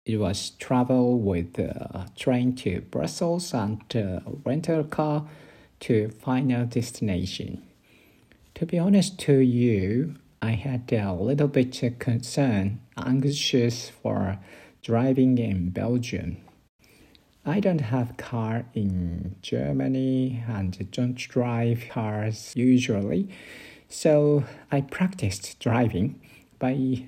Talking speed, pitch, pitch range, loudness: 105 wpm, 120 Hz, 105-135 Hz, -26 LUFS